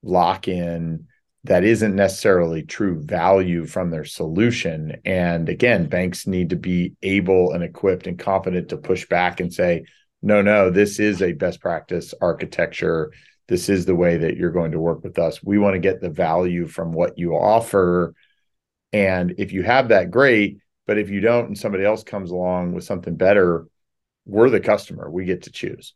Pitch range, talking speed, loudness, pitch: 85-100 Hz, 185 wpm, -20 LUFS, 90 Hz